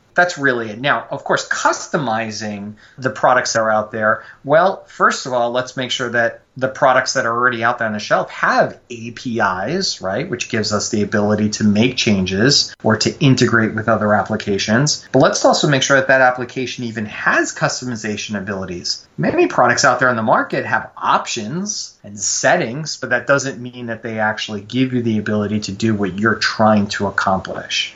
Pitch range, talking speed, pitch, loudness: 105-130 Hz, 190 wpm, 115 Hz, -17 LUFS